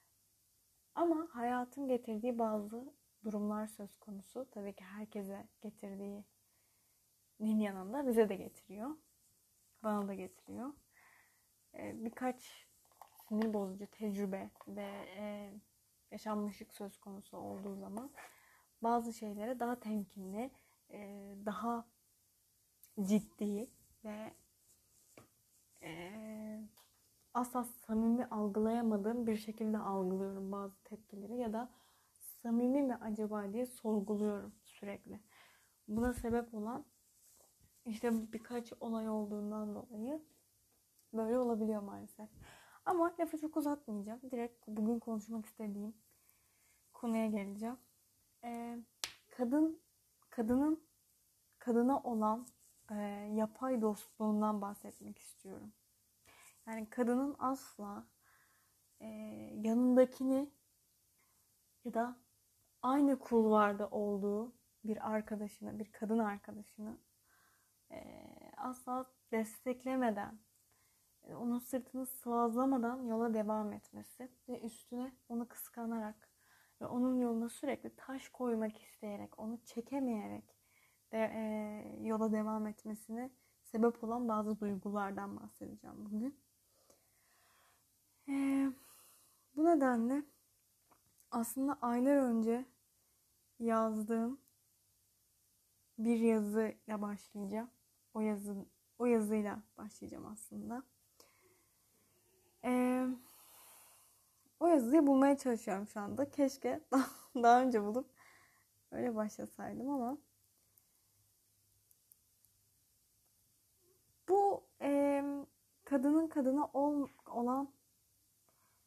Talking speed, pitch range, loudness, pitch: 85 wpm, 200-245 Hz, -38 LUFS, 220 Hz